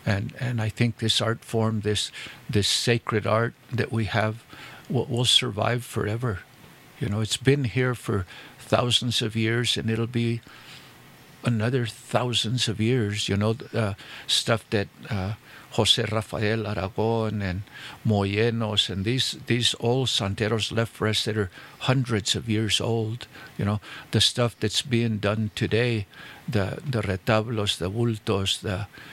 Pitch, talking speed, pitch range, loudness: 110 Hz, 150 wpm, 105-120 Hz, -25 LUFS